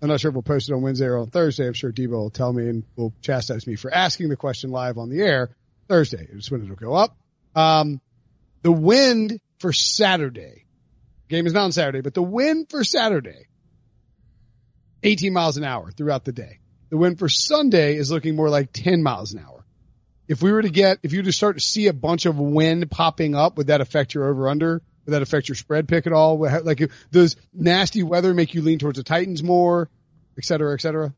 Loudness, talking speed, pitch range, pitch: -20 LUFS, 225 wpm, 130-175 Hz, 155 Hz